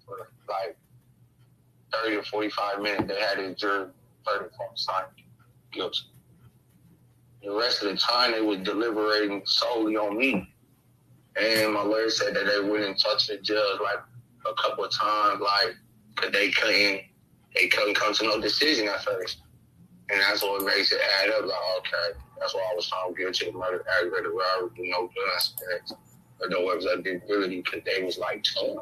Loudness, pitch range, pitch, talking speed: -26 LUFS, 95-110 Hz, 105 Hz, 175 wpm